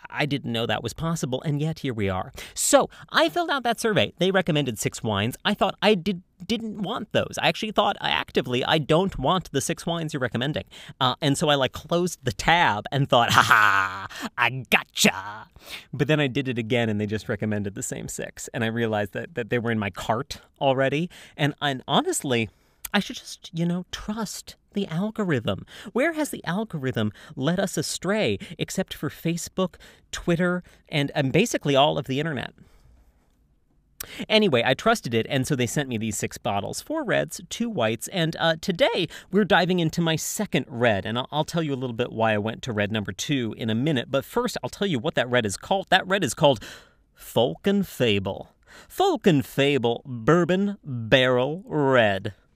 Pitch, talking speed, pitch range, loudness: 145 Hz, 195 wpm, 120-185 Hz, -24 LUFS